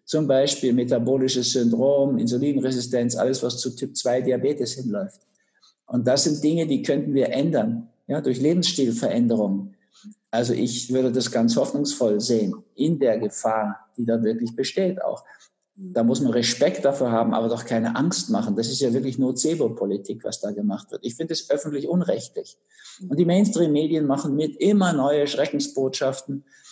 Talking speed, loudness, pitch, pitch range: 155 wpm, -23 LUFS, 135 Hz, 120-160 Hz